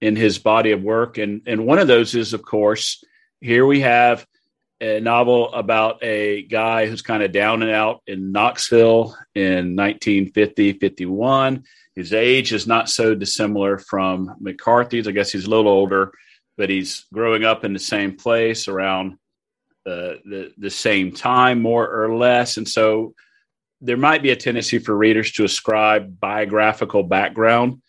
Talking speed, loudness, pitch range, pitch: 165 wpm, -18 LUFS, 100-115 Hz, 110 Hz